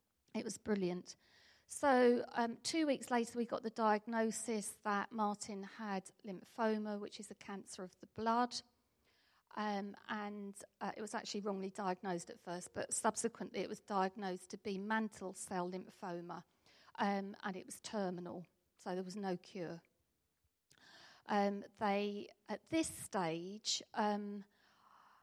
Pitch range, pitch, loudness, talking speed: 190-220 Hz, 205 Hz, -40 LUFS, 140 wpm